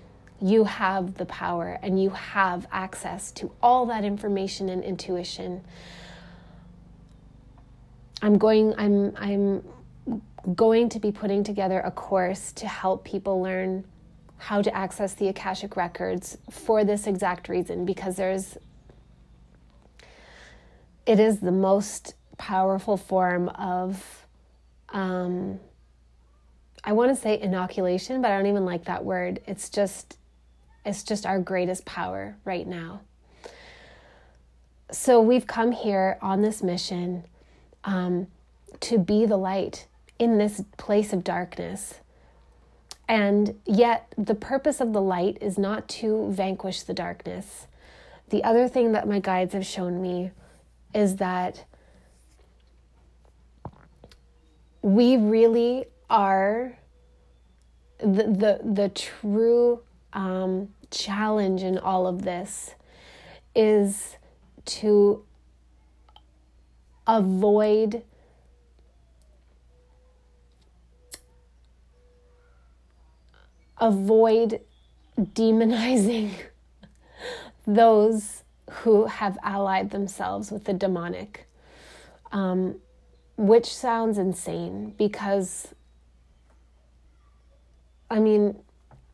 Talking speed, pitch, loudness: 95 wpm, 190 Hz, -25 LUFS